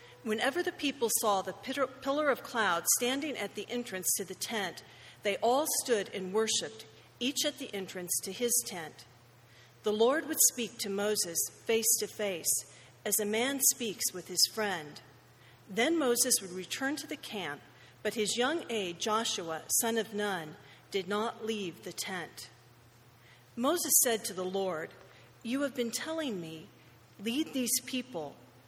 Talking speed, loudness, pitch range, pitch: 160 wpm, -31 LUFS, 185-250 Hz, 215 Hz